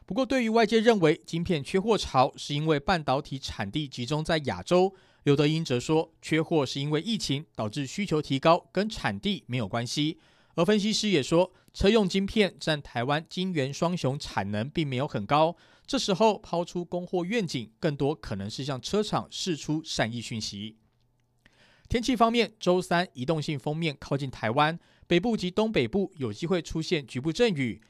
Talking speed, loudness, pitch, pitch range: 275 characters per minute, -27 LUFS, 160 Hz, 135-185 Hz